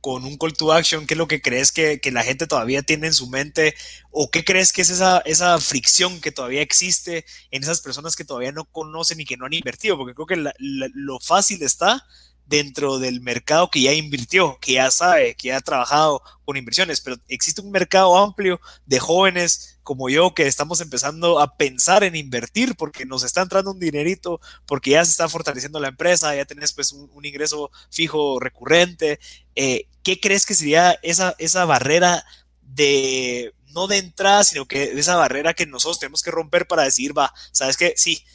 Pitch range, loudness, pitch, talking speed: 135-175 Hz, -18 LUFS, 155 Hz, 200 wpm